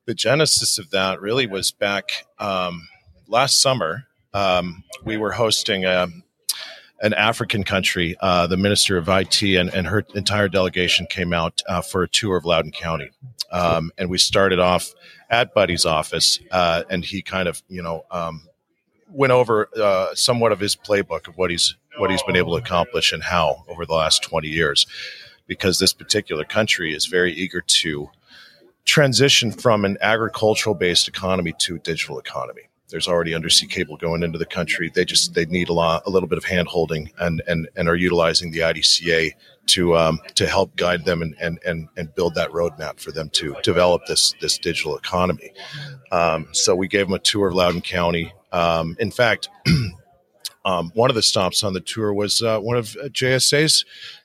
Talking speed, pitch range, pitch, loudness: 185 wpm, 85-105 Hz, 90 Hz, -19 LUFS